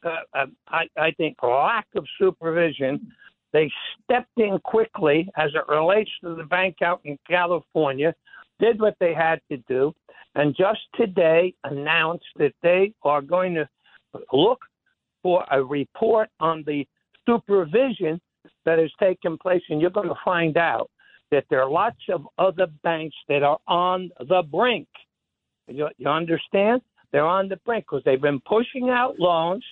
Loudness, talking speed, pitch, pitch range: -23 LUFS, 155 wpm, 175 Hz, 155-205 Hz